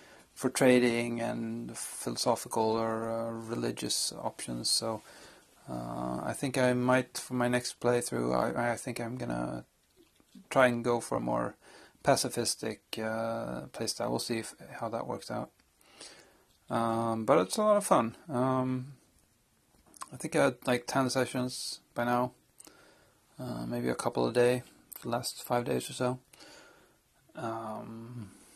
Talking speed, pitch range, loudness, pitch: 145 wpm, 110-125 Hz, -31 LUFS, 120 Hz